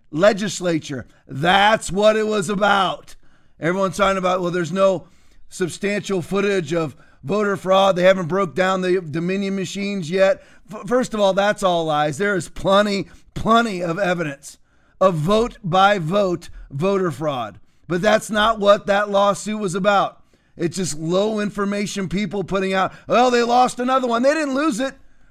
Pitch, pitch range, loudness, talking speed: 195 Hz, 180-210 Hz, -19 LUFS, 160 wpm